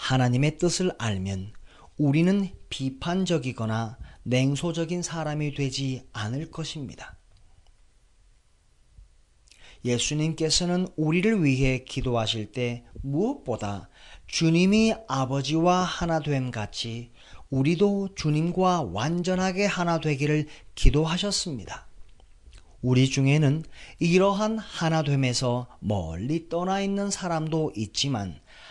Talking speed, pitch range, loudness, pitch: 230 characters per minute, 120-170 Hz, -26 LUFS, 145 Hz